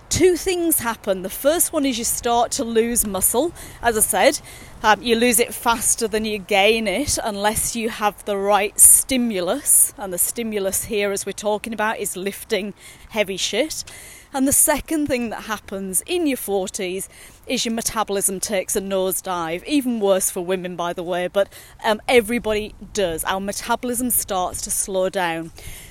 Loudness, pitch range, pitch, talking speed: -19 LUFS, 190-240 Hz, 210 Hz, 170 wpm